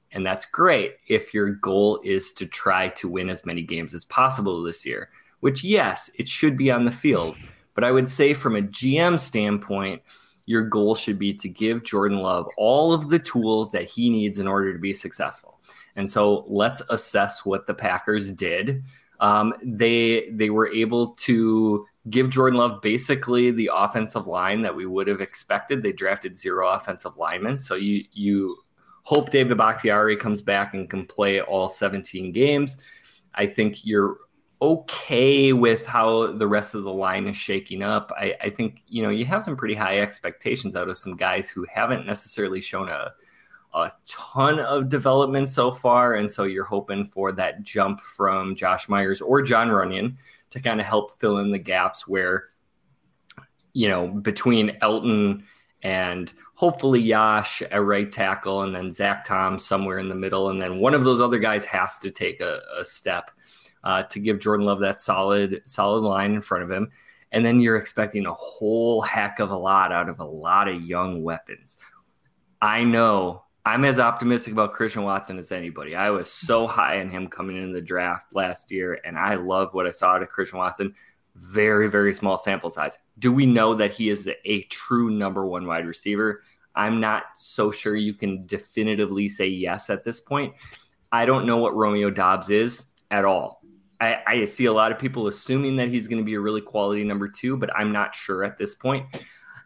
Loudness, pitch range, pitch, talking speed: -23 LUFS, 100-120 Hz, 105 Hz, 190 wpm